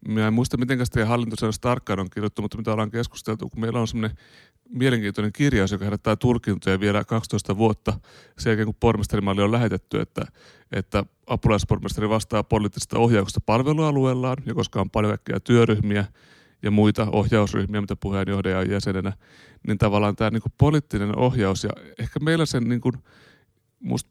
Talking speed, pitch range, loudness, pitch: 150 wpm, 105-120 Hz, -23 LUFS, 110 Hz